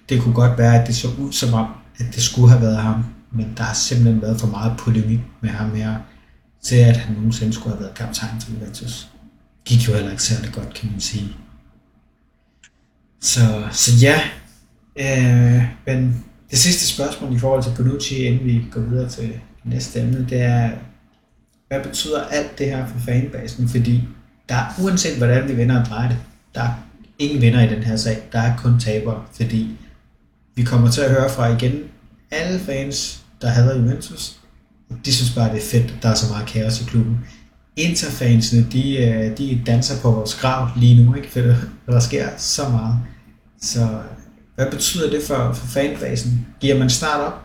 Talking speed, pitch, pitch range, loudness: 190 wpm, 120 Hz, 115-130 Hz, -18 LUFS